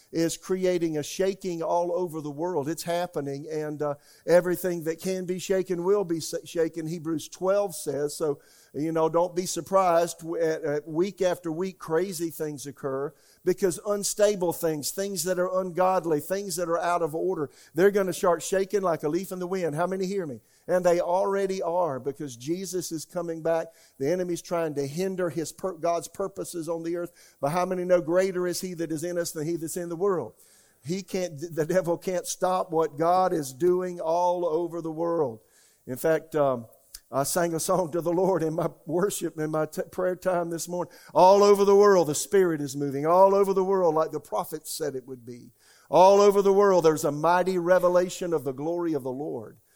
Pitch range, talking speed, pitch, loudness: 160-185 Hz, 205 wpm, 175 Hz, -26 LUFS